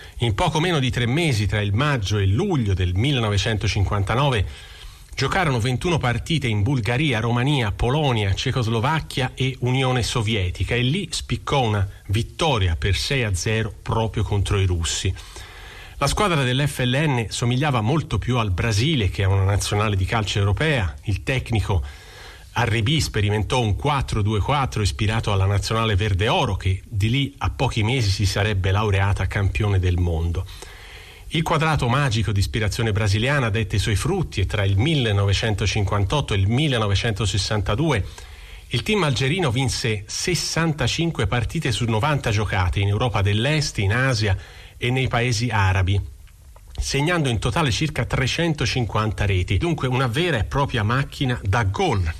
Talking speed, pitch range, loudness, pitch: 145 wpm, 100-130 Hz, -21 LUFS, 110 Hz